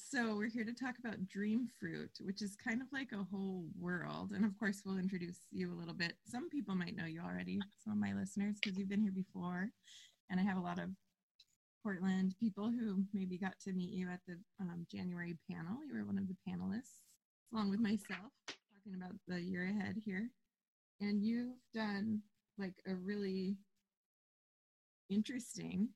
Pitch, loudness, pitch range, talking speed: 200 Hz, -42 LUFS, 185-215 Hz, 185 wpm